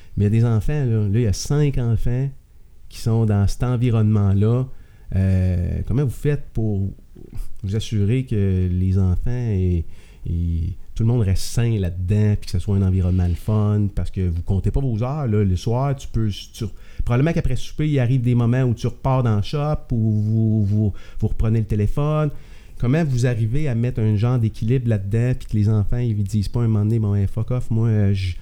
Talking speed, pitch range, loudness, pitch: 220 wpm, 100-125 Hz, -21 LUFS, 110 Hz